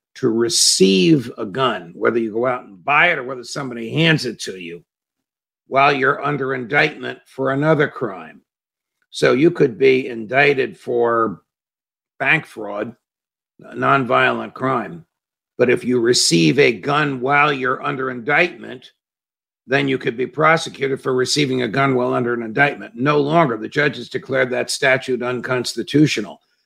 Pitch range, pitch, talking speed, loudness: 125-150 Hz, 135 Hz, 150 wpm, -17 LUFS